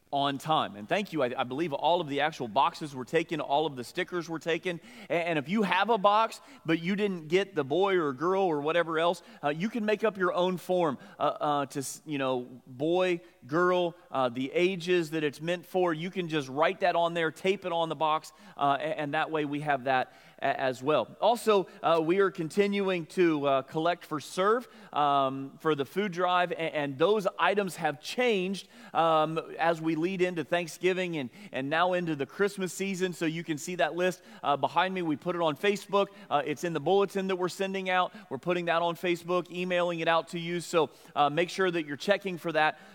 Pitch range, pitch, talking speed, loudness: 150-185 Hz, 170 Hz, 220 wpm, -29 LUFS